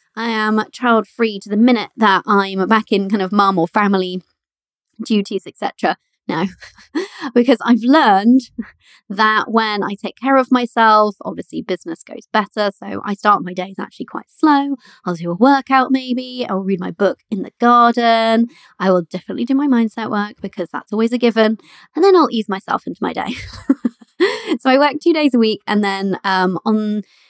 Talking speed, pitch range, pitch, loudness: 185 wpm, 200-250 Hz, 220 Hz, -16 LUFS